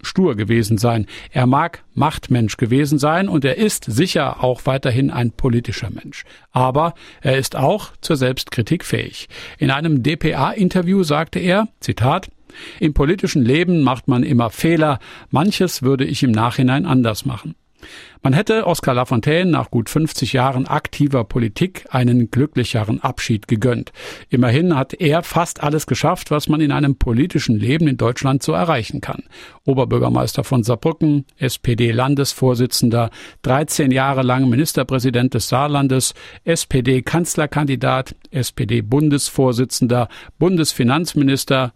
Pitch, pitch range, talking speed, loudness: 135 Hz, 125-155 Hz, 130 wpm, -17 LUFS